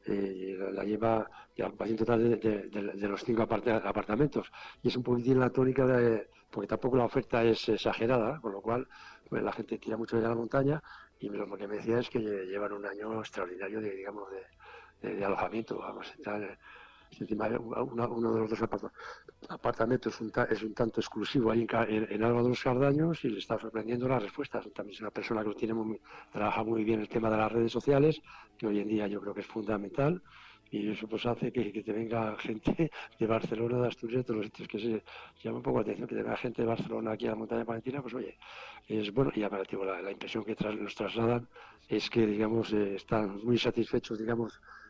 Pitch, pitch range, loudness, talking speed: 115 Hz, 105-120 Hz, -32 LUFS, 220 wpm